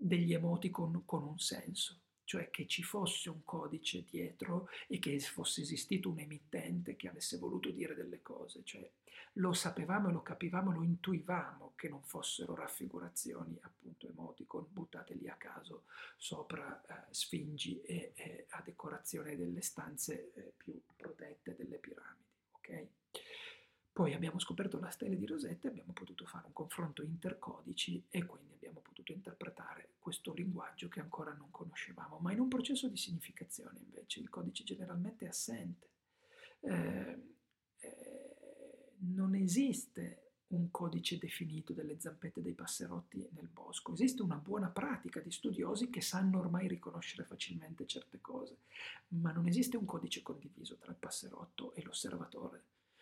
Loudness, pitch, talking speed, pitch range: -42 LUFS, 175 Hz, 145 wpm, 160-200 Hz